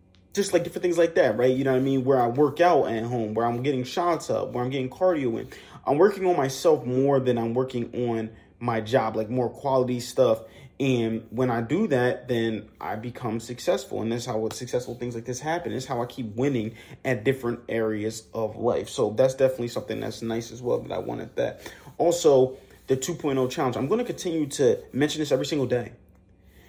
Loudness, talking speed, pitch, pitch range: -25 LUFS, 215 wpm, 125 Hz, 115-135 Hz